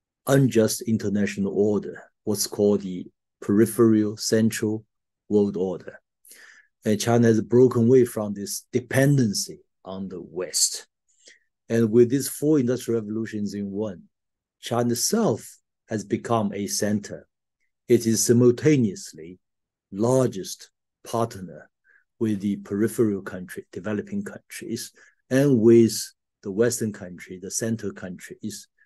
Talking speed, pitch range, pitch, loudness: 110 wpm, 100-120 Hz, 110 Hz, -23 LUFS